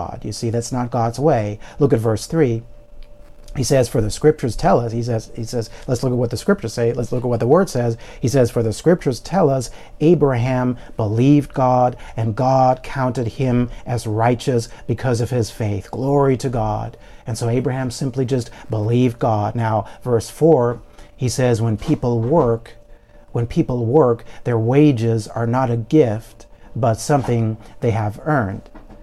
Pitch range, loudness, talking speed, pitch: 115-130 Hz, -19 LUFS, 180 wpm, 120 Hz